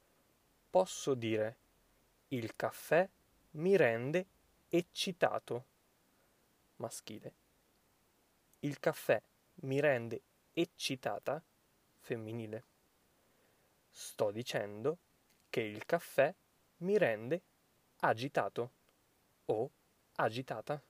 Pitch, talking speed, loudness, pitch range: 140 Hz, 70 wpm, -37 LUFS, 115-170 Hz